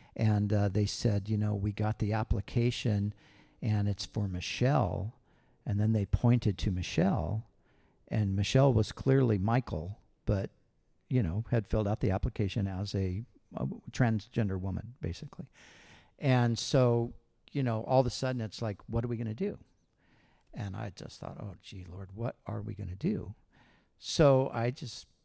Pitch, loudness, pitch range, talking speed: 110 Hz, -32 LUFS, 100-120 Hz, 170 wpm